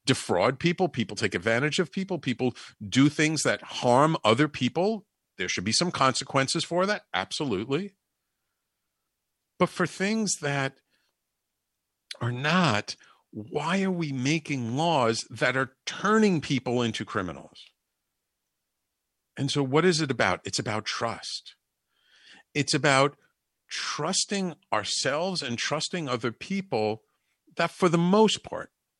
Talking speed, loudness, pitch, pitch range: 125 wpm, -26 LUFS, 145 Hz, 120-175 Hz